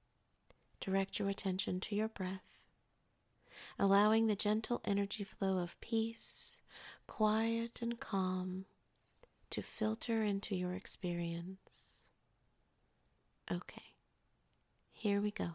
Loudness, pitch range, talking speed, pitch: -38 LUFS, 185-215 Hz, 95 wpm, 200 Hz